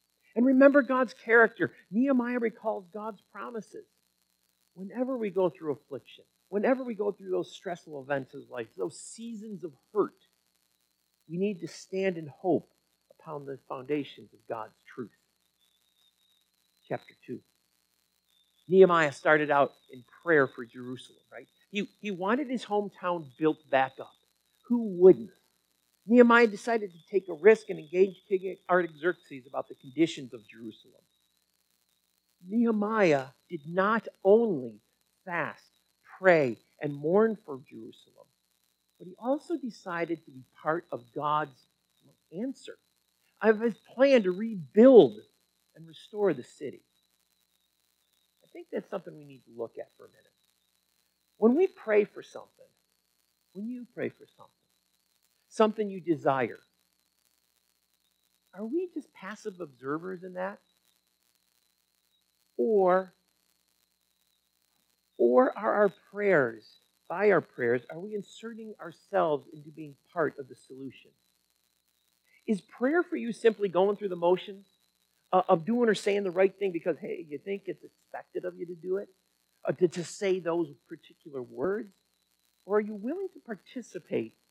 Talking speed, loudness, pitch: 135 wpm, -28 LUFS, 170 Hz